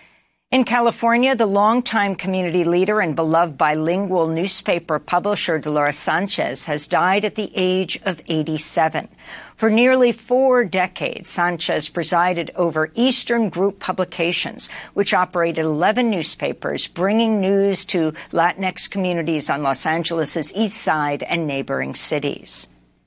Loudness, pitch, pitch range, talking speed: -19 LUFS, 180 Hz, 160-205 Hz, 120 wpm